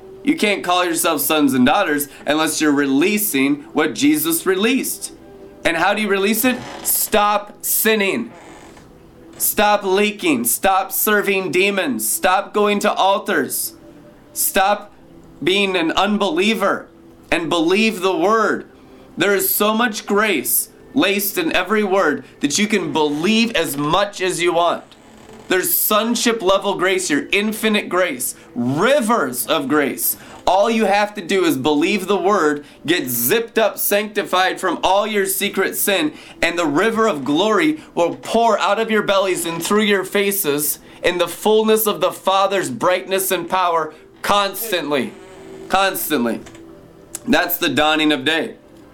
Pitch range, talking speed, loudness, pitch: 180-215 Hz, 140 wpm, -17 LUFS, 200 Hz